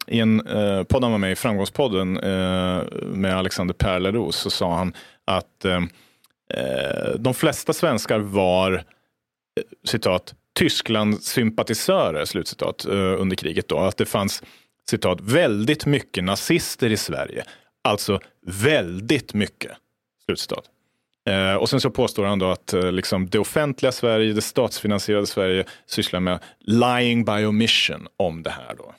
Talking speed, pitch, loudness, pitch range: 140 wpm, 105 Hz, -22 LUFS, 95-115 Hz